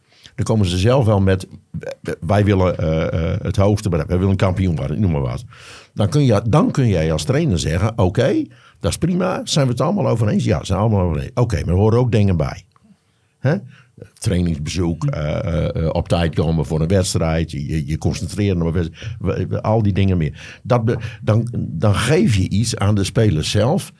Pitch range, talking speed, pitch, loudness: 85-115 Hz, 200 wpm, 100 Hz, -18 LUFS